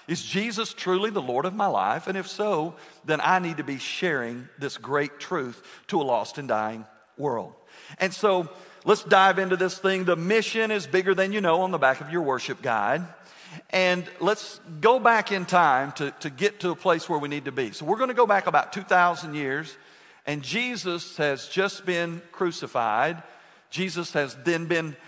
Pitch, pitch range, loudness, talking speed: 175 Hz, 150-195 Hz, -25 LUFS, 200 wpm